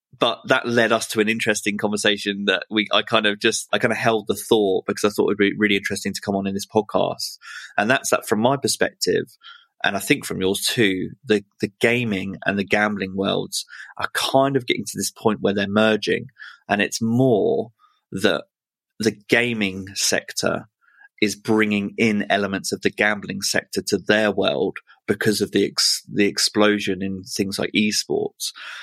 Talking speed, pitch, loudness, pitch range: 190 wpm, 105 Hz, -21 LUFS, 100-115 Hz